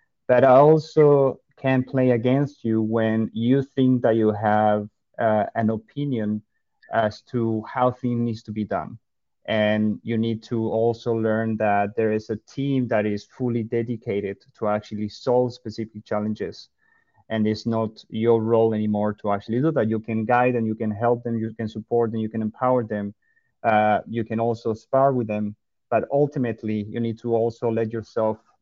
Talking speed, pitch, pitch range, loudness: 180 wpm, 115 Hz, 110-120 Hz, -23 LUFS